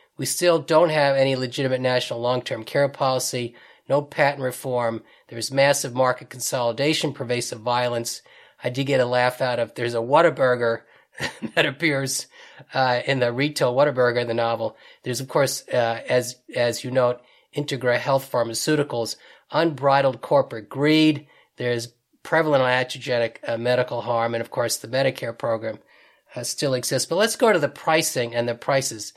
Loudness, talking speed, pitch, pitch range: -22 LUFS, 160 wpm, 125 Hz, 120-140 Hz